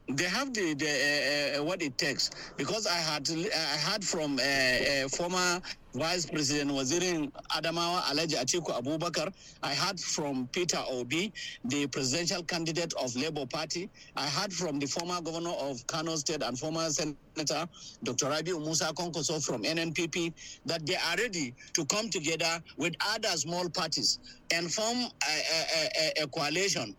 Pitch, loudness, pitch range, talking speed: 165 Hz, -31 LUFS, 150-180 Hz, 160 wpm